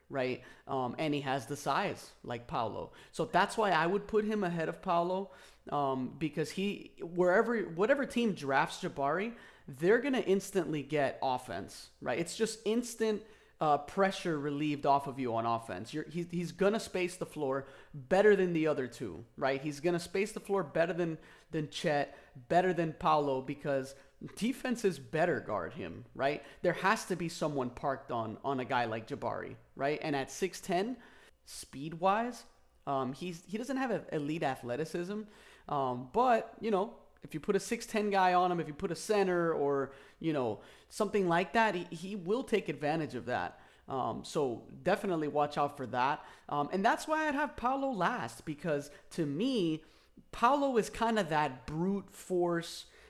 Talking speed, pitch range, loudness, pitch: 175 wpm, 145-200 Hz, -33 LUFS, 170 Hz